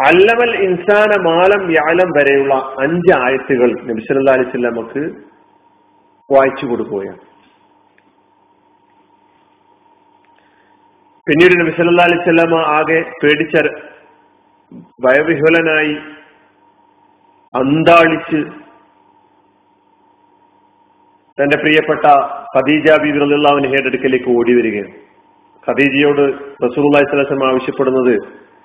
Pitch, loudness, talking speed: 170 Hz, -12 LUFS, 55 wpm